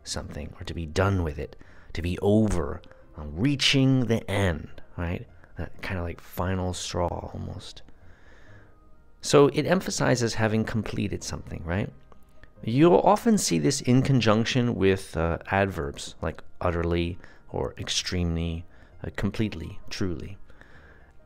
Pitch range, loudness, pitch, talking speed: 85-110 Hz, -26 LUFS, 95 Hz, 125 wpm